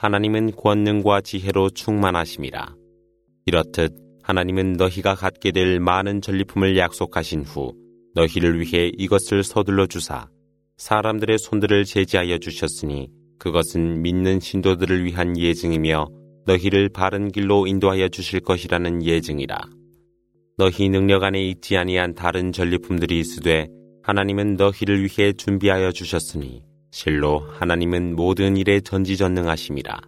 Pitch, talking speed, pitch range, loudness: 95 Hz, 320 characters per minute, 85-100 Hz, -21 LUFS